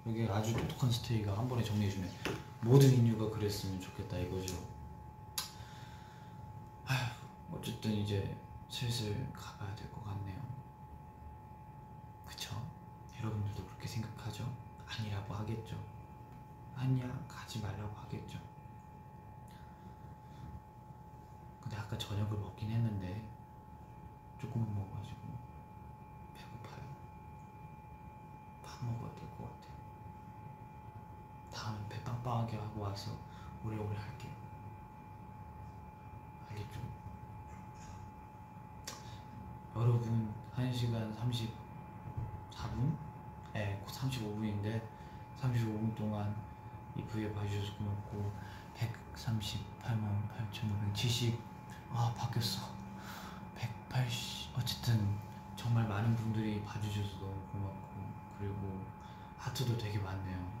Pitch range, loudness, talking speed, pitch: 105-120 Hz, -39 LUFS, 190 characters per minute, 110 Hz